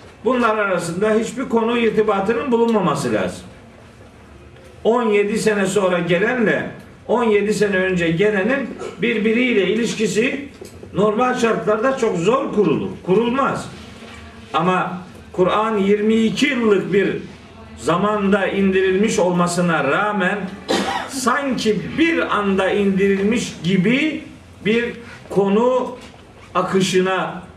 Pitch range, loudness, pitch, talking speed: 190-230 Hz, -18 LUFS, 210 Hz, 85 wpm